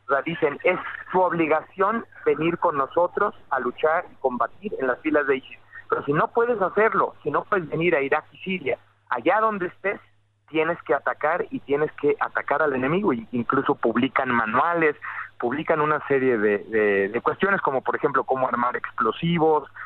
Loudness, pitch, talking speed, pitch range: -23 LUFS, 155 Hz, 170 wpm, 130-185 Hz